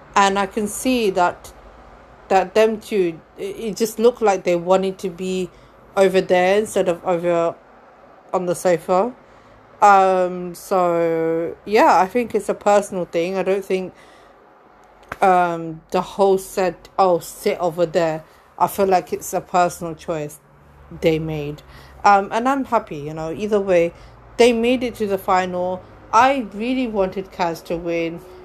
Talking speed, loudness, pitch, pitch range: 155 wpm, -19 LUFS, 185 Hz, 175-205 Hz